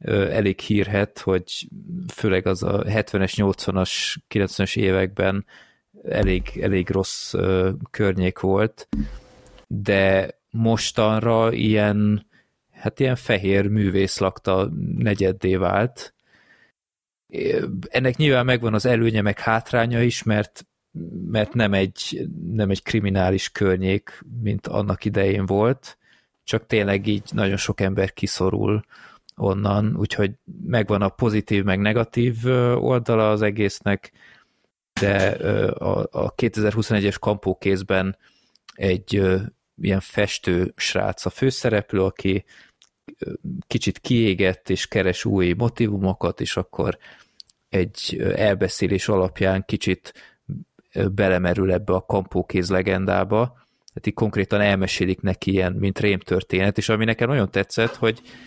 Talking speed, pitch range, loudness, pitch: 105 wpm, 95-110 Hz, -22 LUFS, 100 Hz